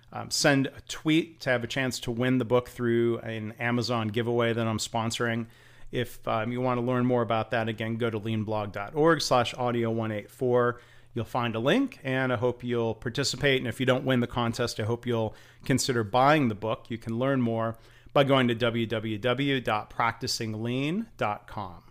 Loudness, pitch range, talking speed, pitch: -27 LUFS, 115-125 Hz, 180 wpm, 120 Hz